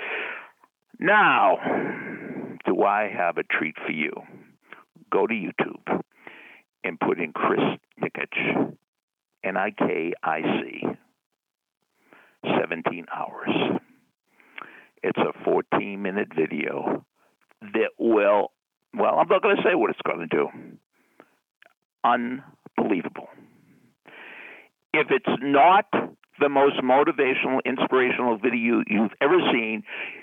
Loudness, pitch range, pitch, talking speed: -24 LUFS, 105-130 Hz, 120 Hz, 105 wpm